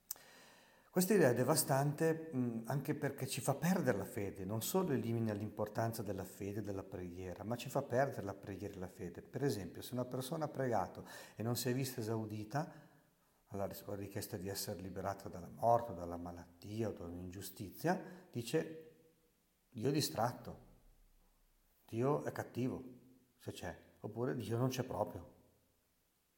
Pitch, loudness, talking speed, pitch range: 115 Hz, -40 LUFS, 150 wpm, 100-135 Hz